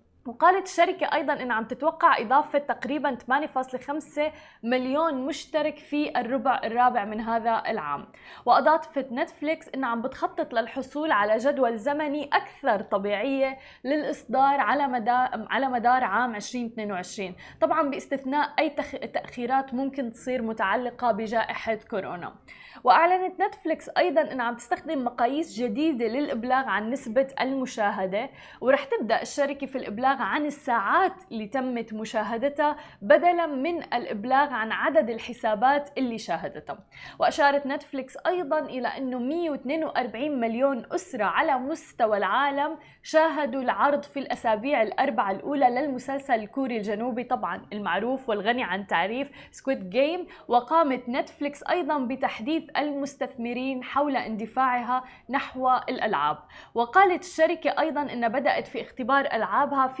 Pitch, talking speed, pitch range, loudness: 270 Hz, 120 wpm, 240-295 Hz, -26 LUFS